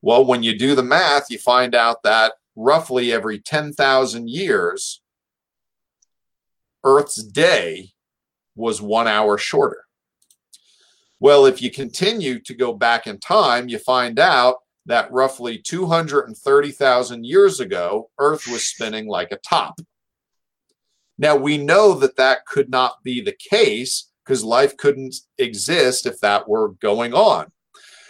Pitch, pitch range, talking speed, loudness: 135 Hz, 120-185 Hz, 130 wpm, -18 LUFS